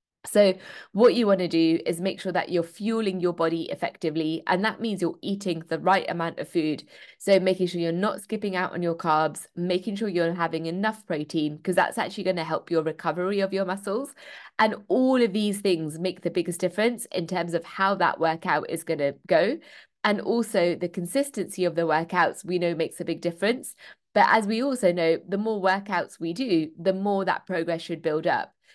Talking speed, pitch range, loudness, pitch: 210 wpm, 165-195 Hz, -25 LUFS, 180 Hz